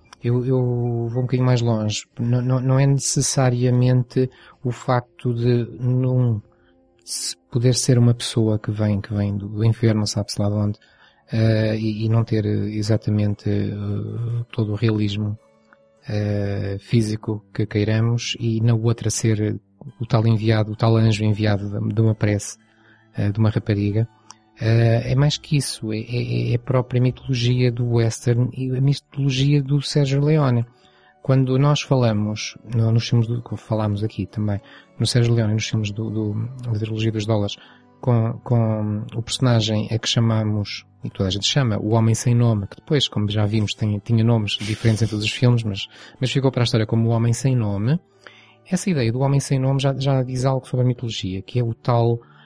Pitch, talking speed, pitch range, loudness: 115 Hz, 180 wpm, 105-125 Hz, -21 LUFS